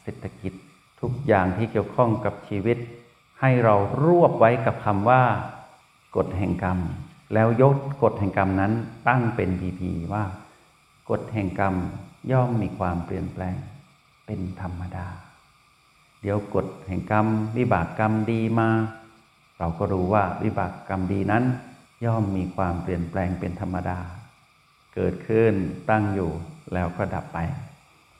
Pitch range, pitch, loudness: 95-115 Hz, 105 Hz, -24 LUFS